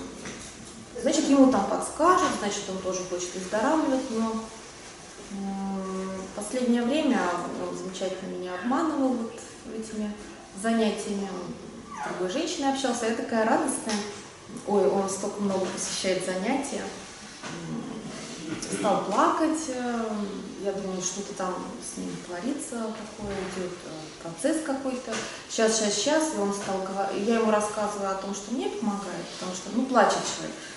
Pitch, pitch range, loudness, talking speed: 210 Hz, 195-250 Hz, -28 LUFS, 125 wpm